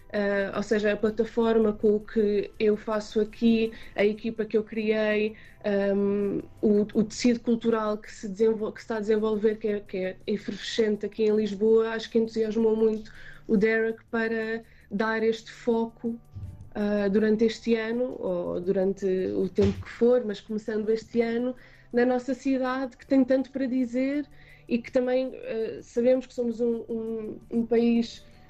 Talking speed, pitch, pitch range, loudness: 170 wpm, 225 Hz, 210-235 Hz, -27 LUFS